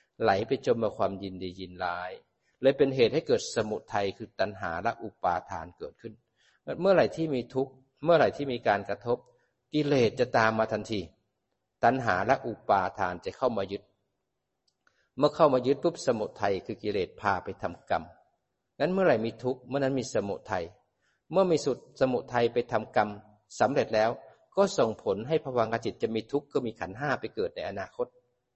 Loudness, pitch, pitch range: -29 LUFS, 125 Hz, 105-150 Hz